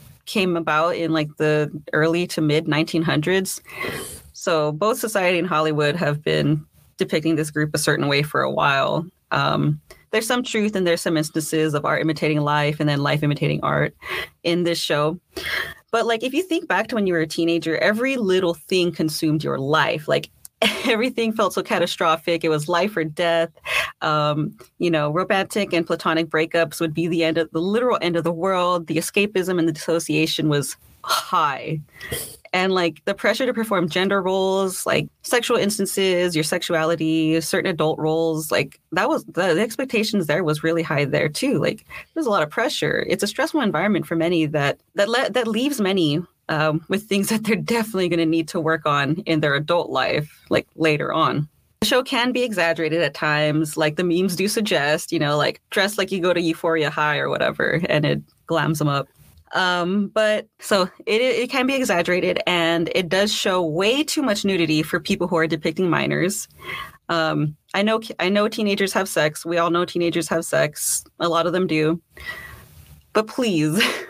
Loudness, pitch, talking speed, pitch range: -21 LUFS, 170 Hz, 190 wpm, 155-195 Hz